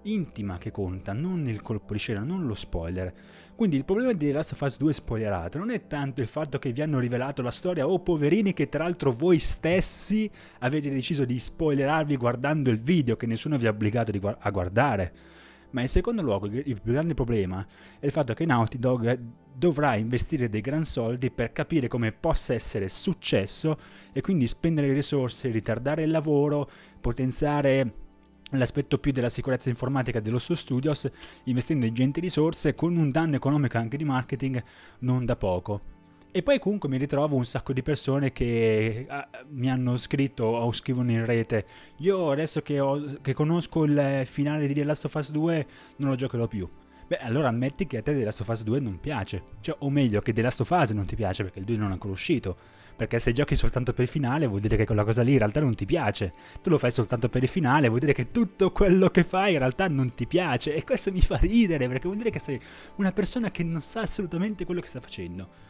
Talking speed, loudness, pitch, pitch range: 205 wpm, -27 LUFS, 135 Hz, 115-150 Hz